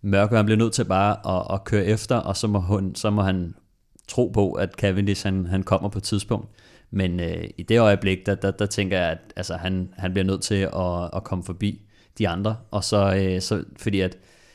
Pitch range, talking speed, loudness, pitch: 95-105 Hz, 225 wpm, -24 LUFS, 100 Hz